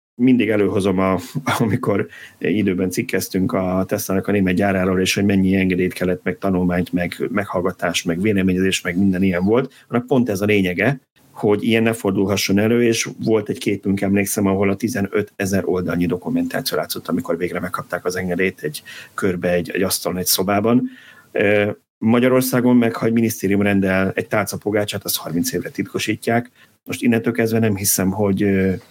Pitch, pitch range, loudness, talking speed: 100 Hz, 95-110 Hz, -19 LUFS, 160 wpm